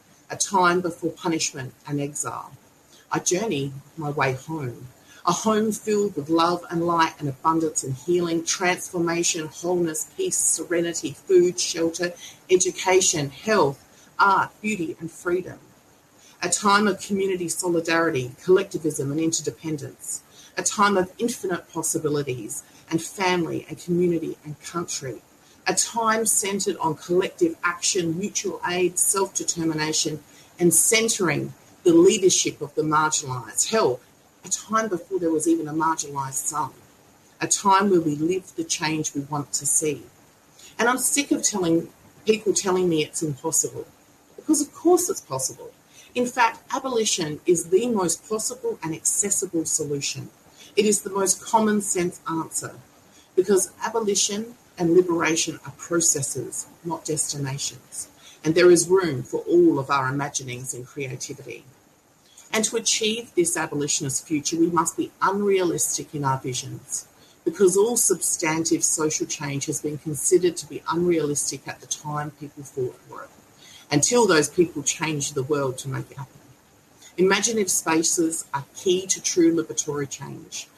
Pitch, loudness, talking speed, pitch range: 165 Hz, -23 LUFS, 140 wpm, 150-195 Hz